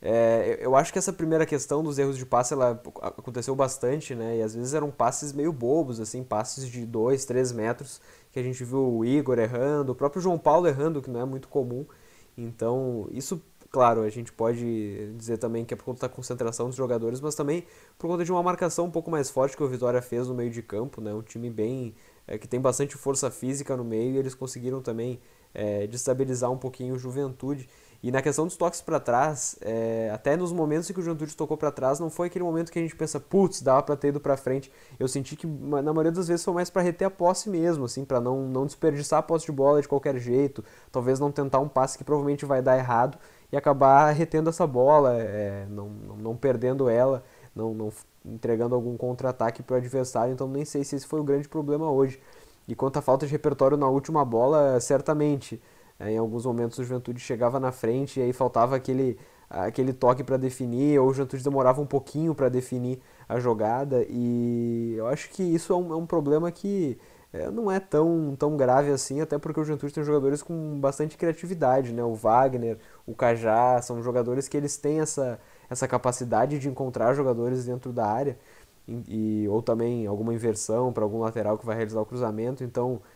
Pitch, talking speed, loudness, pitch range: 130 Hz, 215 wpm, -26 LUFS, 120-145 Hz